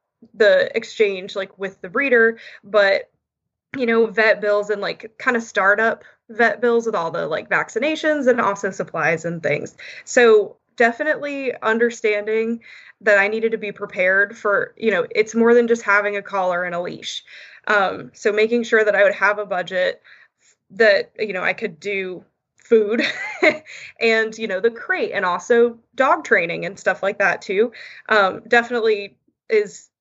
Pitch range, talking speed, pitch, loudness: 200-245 Hz, 170 wpm, 225 Hz, -19 LUFS